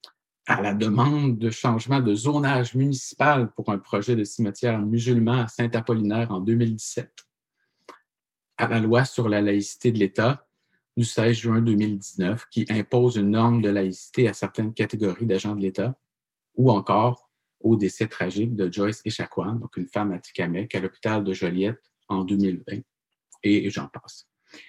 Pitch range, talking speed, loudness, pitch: 100-120 Hz, 155 wpm, -24 LUFS, 110 Hz